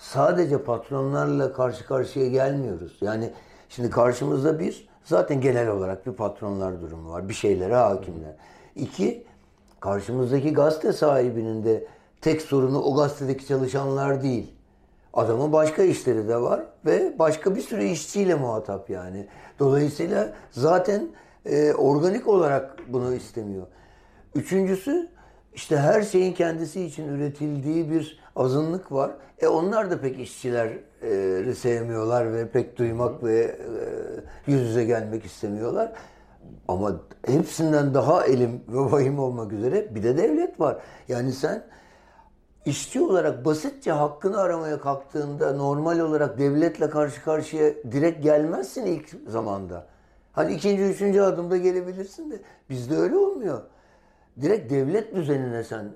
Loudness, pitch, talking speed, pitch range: -24 LUFS, 140 Hz, 125 wpm, 120-160 Hz